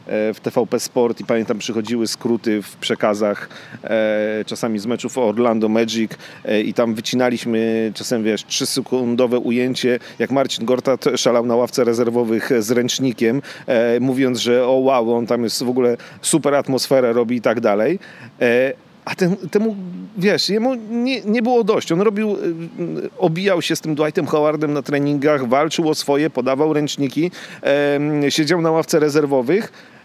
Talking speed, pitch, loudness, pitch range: 160 wpm, 130 Hz, -18 LUFS, 120-155 Hz